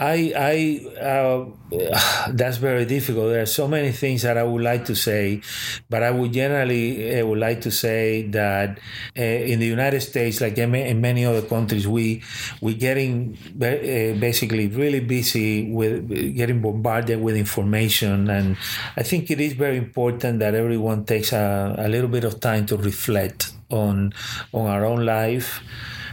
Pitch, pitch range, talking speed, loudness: 115 Hz, 110-125 Hz, 160 wpm, -22 LUFS